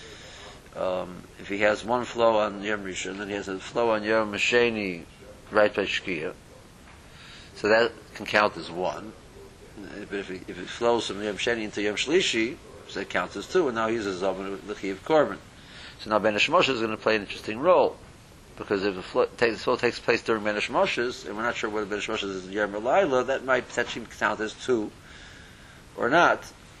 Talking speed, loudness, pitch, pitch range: 195 wpm, -26 LUFS, 105 Hz, 100-115 Hz